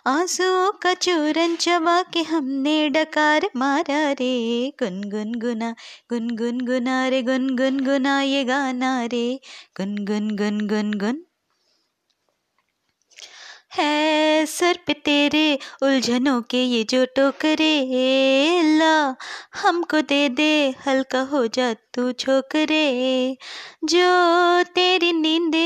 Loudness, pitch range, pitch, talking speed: -20 LUFS, 255-320 Hz, 275 Hz, 110 wpm